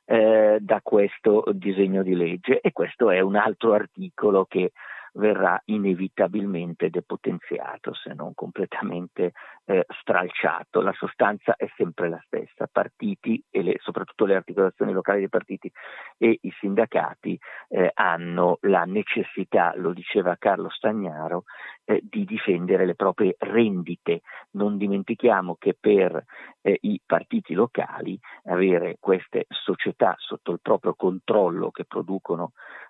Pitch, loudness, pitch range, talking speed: 100 Hz, -24 LUFS, 95-110 Hz, 125 wpm